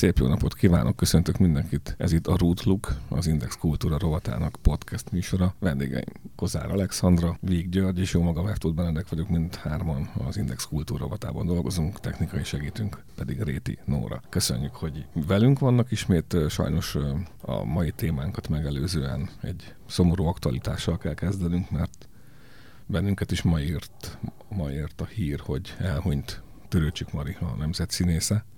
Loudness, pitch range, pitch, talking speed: -27 LUFS, 80-95 Hz, 85 Hz, 145 wpm